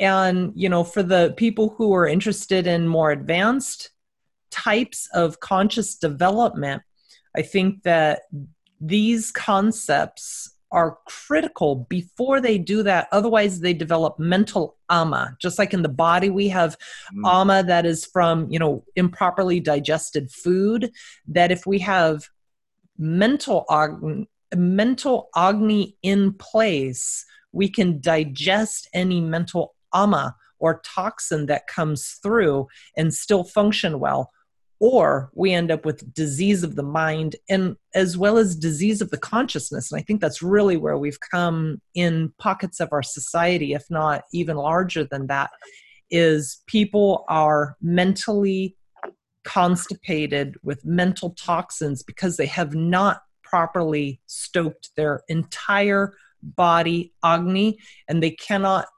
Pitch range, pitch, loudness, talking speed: 160-200 Hz, 180 Hz, -21 LUFS, 130 wpm